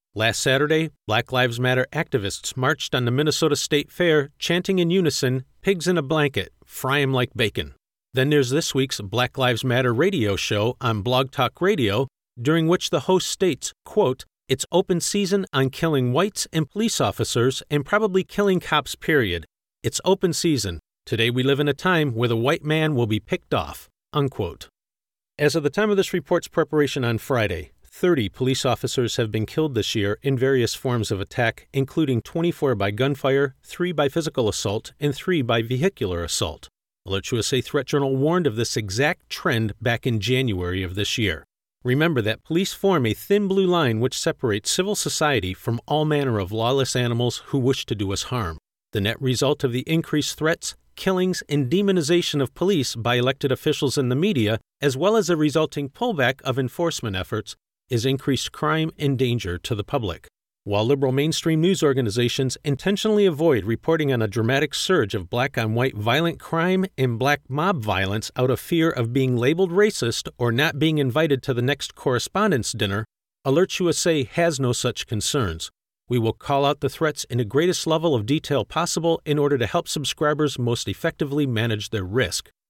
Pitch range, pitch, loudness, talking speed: 120-160 Hz, 135 Hz, -22 LUFS, 180 wpm